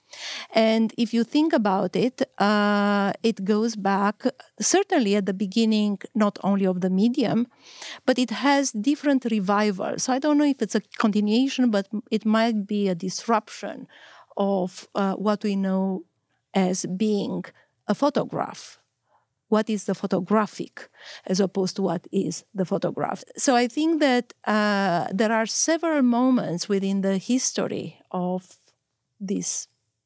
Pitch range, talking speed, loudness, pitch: 195-240 Hz, 145 wpm, -24 LUFS, 210 Hz